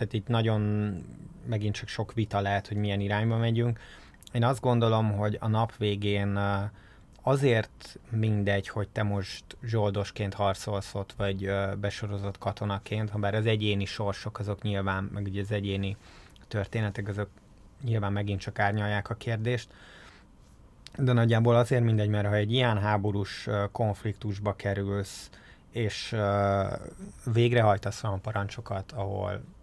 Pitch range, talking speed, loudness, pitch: 100-115 Hz, 130 wpm, -29 LUFS, 105 Hz